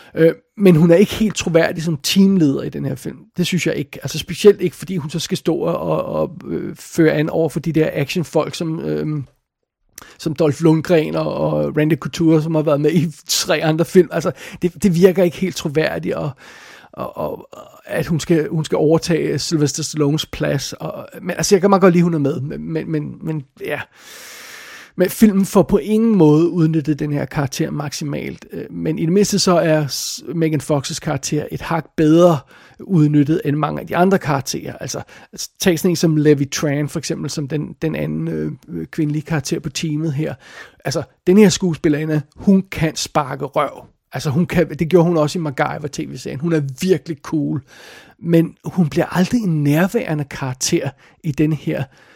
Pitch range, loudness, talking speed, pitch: 150-175 Hz, -18 LUFS, 190 wpm, 160 Hz